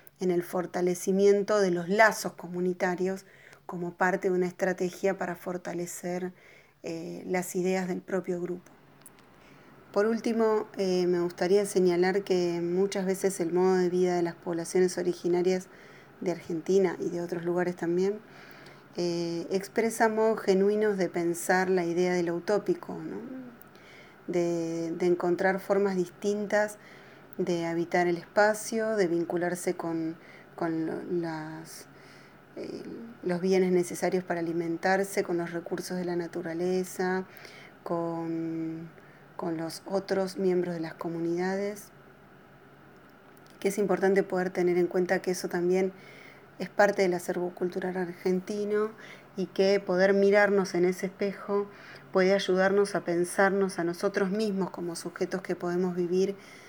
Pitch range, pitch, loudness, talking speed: 175-195 Hz, 185 Hz, -29 LUFS, 130 wpm